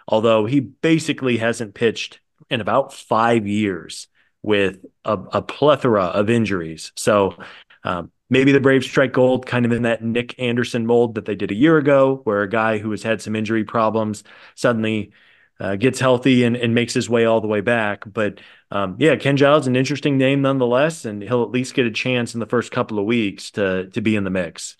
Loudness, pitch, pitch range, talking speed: -19 LUFS, 115 Hz, 105-130 Hz, 205 wpm